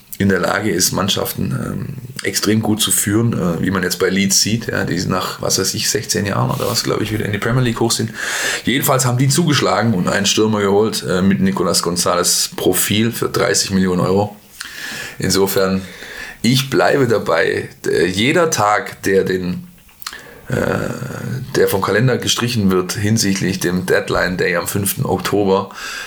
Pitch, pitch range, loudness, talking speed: 100 Hz, 95-115 Hz, -16 LUFS, 175 wpm